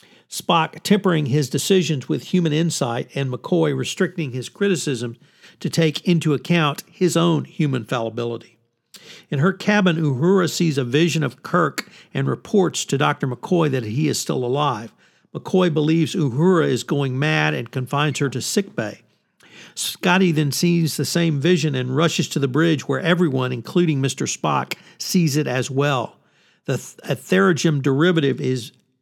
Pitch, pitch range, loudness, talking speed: 155 Hz, 135-175 Hz, -20 LUFS, 155 wpm